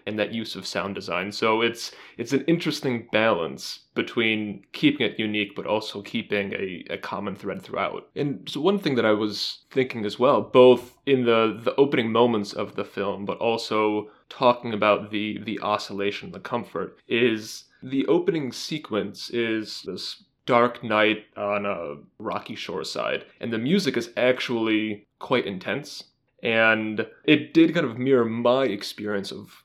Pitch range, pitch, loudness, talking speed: 105-125 Hz, 110 Hz, -24 LUFS, 160 wpm